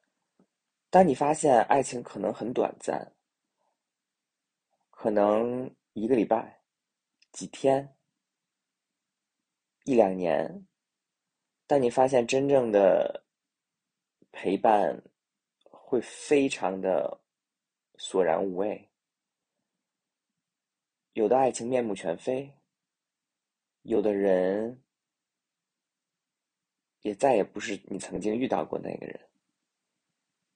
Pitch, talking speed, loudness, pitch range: 120 Hz, 125 characters per minute, -27 LUFS, 105-135 Hz